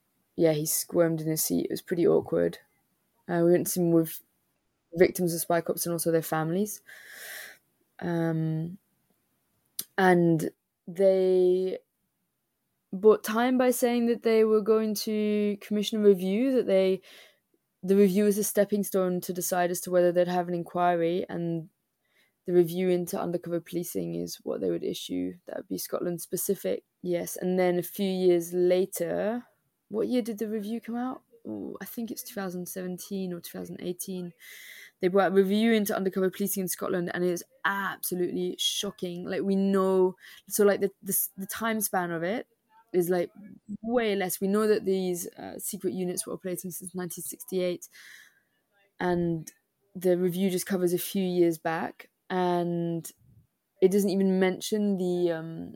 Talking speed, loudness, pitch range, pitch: 160 wpm, -28 LUFS, 175-205 Hz, 185 Hz